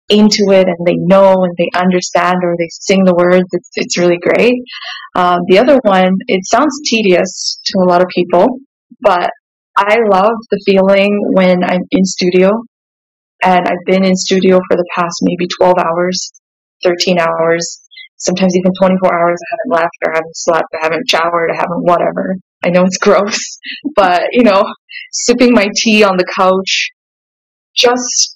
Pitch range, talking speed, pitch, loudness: 180-220 Hz, 175 wpm, 185 Hz, -11 LUFS